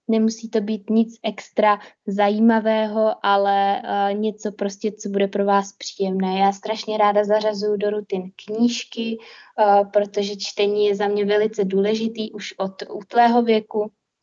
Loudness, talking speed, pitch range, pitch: -21 LUFS, 145 wpm, 200-220 Hz, 210 Hz